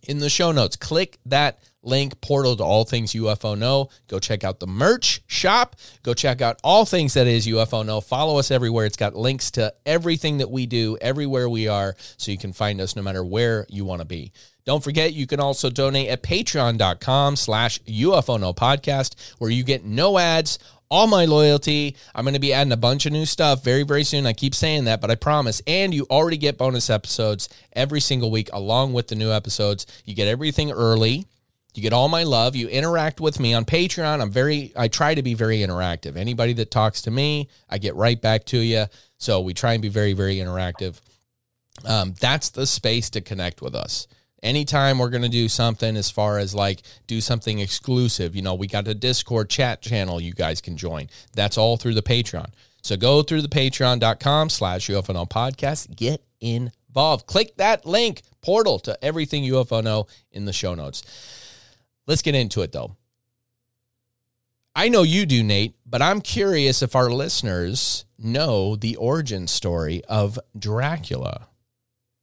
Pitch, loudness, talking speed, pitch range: 120 Hz, -21 LUFS, 190 wpm, 110-140 Hz